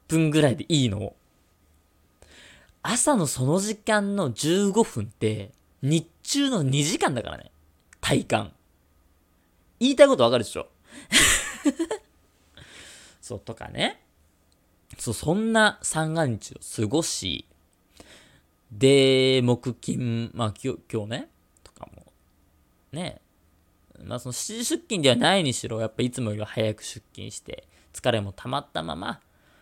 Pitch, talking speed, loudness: 120 Hz, 220 characters per minute, -24 LUFS